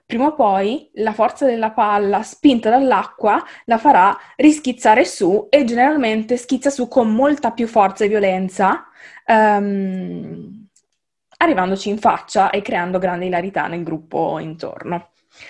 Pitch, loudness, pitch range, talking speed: 215 Hz, -17 LUFS, 195-255 Hz, 130 wpm